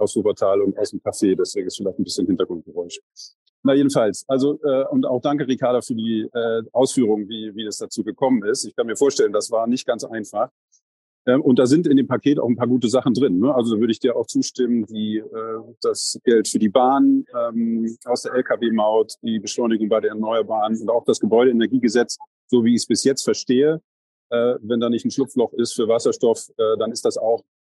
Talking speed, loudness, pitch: 220 wpm, -20 LUFS, 125 Hz